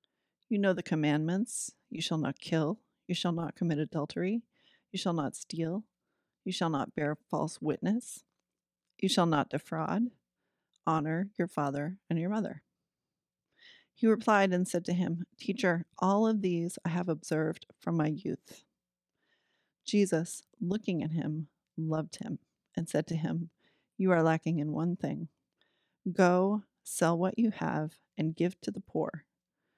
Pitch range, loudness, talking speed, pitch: 160-200 Hz, -32 LUFS, 150 wpm, 175 Hz